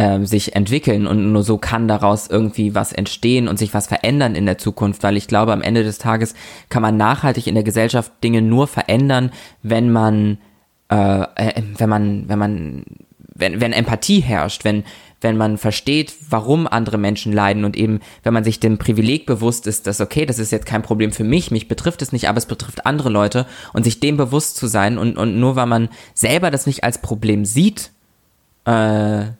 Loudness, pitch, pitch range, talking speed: -17 LUFS, 110 Hz, 105-120 Hz, 200 wpm